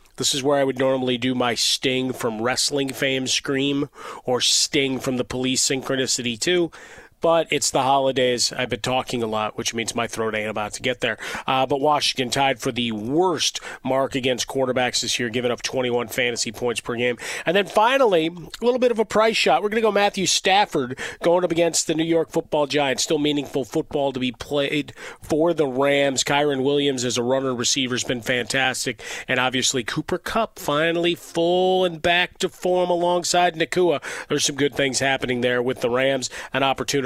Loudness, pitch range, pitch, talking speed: -21 LUFS, 125-160 Hz, 135 Hz, 200 wpm